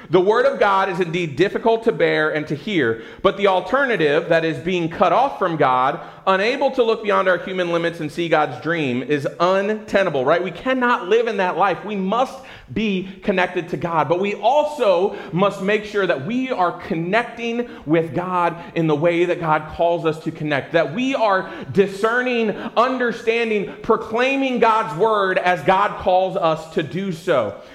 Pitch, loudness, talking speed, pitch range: 190 Hz, -19 LUFS, 180 wpm, 170-225 Hz